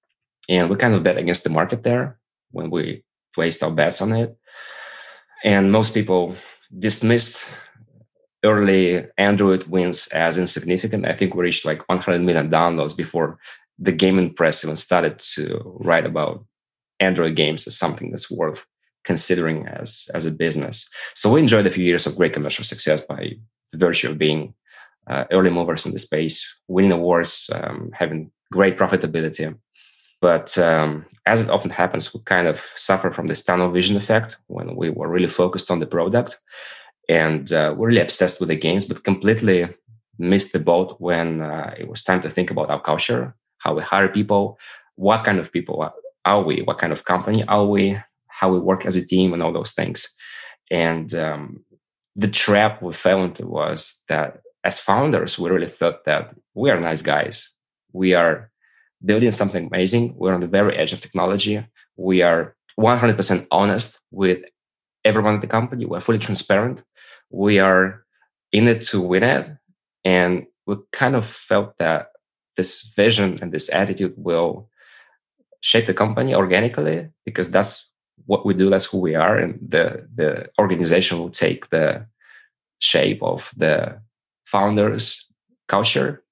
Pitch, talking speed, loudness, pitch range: 95 Hz, 165 wpm, -19 LUFS, 85-110 Hz